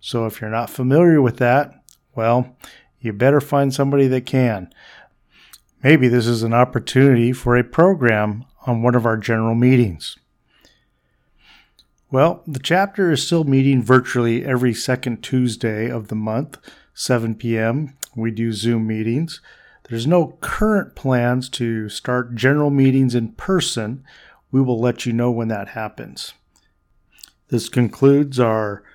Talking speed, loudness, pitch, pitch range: 140 wpm, -18 LUFS, 125 Hz, 115-135 Hz